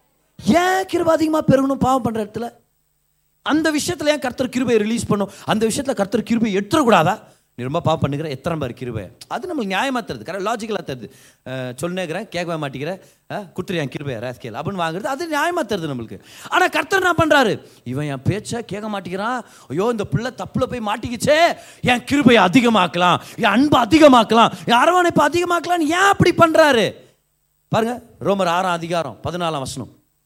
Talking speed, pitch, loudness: 155 wpm, 210 Hz, -18 LUFS